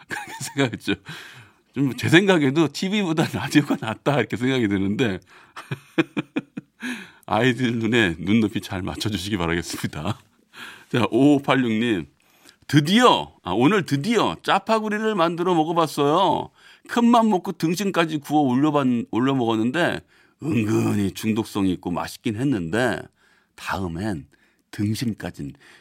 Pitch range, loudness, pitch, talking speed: 105-160 Hz, -22 LUFS, 125 Hz, 265 characters per minute